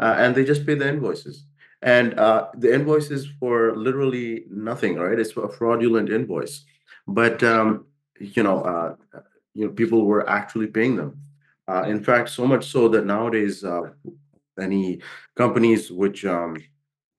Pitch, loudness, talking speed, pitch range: 115 Hz, -21 LUFS, 155 wpm, 105-135 Hz